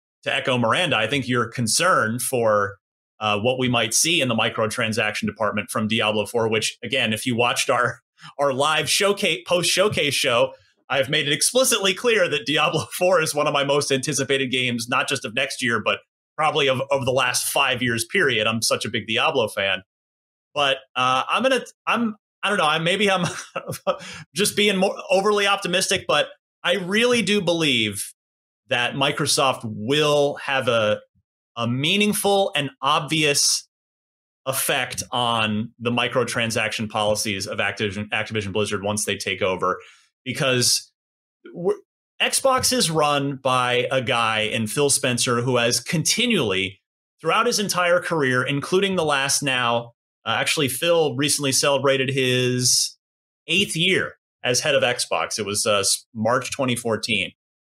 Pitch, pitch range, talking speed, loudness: 135 Hz, 115-170 Hz, 155 wpm, -21 LUFS